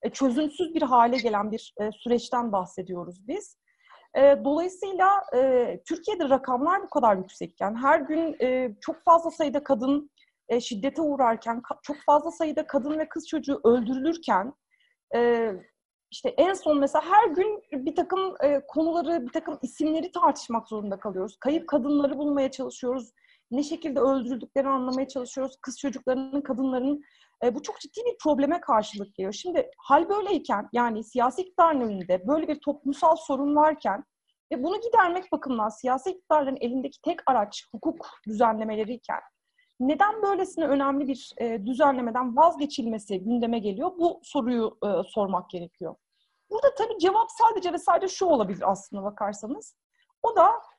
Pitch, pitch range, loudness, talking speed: 280 Hz, 240-335 Hz, -26 LUFS, 145 wpm